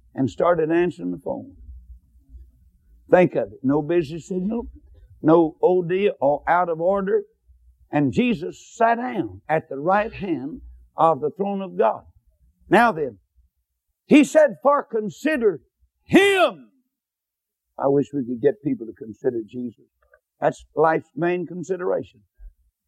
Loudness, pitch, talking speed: -21 LUFS, 160 Hz, 135 wpm